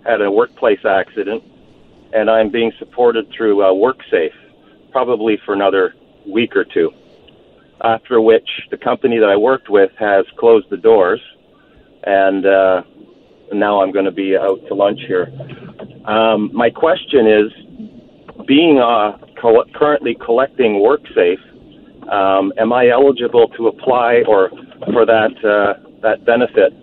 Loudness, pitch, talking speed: -14 LUFS, 120 Hz, 140 wpm